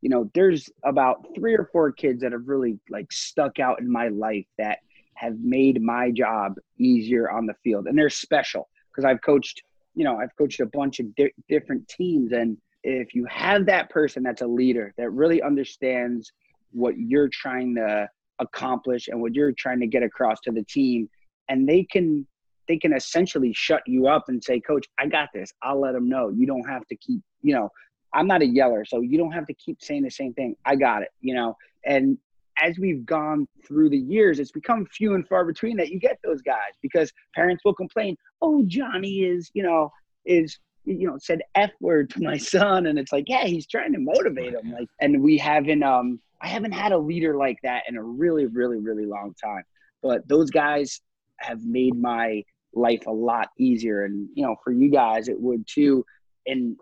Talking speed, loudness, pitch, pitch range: 210 wpm, -23 LUFS, 140 Hz, 120-185 Hz